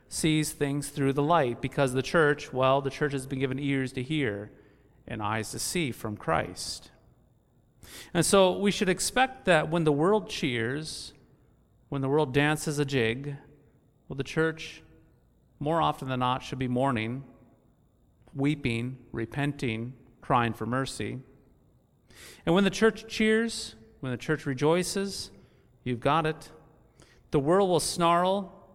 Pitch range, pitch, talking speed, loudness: 125-160 Hz, 140 Hz, 145 wpm, -28 LUFS